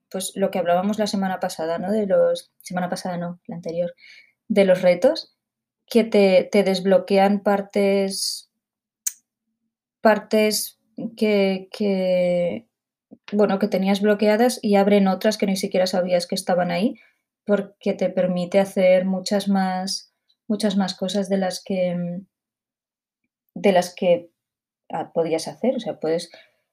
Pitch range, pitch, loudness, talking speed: 185-215 Hz, 195 Hz, -21 LUFS, 135 wpm